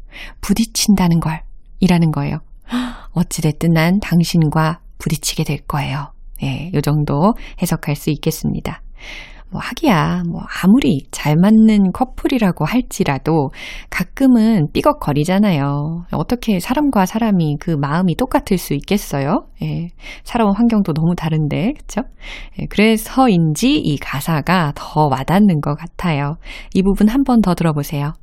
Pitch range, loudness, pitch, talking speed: 155-210 Hz, -16 LUFS, 175 Hz, 285 characters per minute